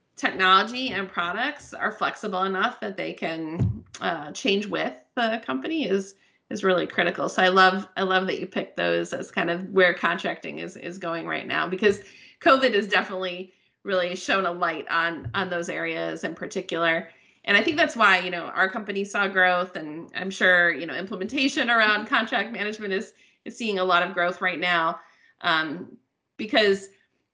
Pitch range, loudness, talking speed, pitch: 175-205 Hz, -24 LUFS, 180 wpm, 190 Hz